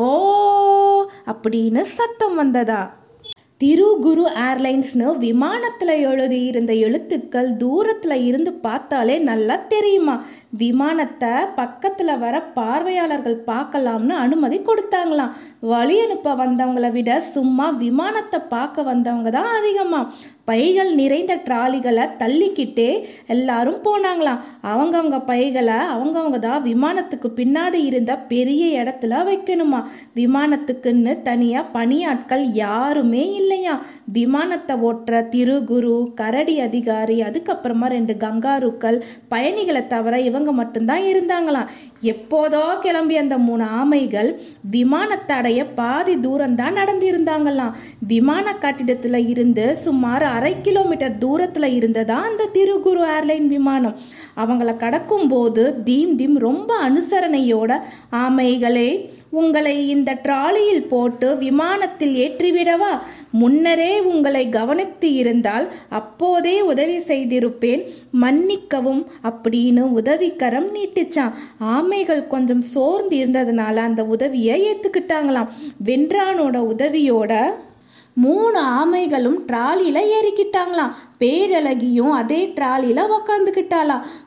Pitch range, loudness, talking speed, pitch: 245-335 Hz, -18 LUFS, 90 wpm, 275 Hz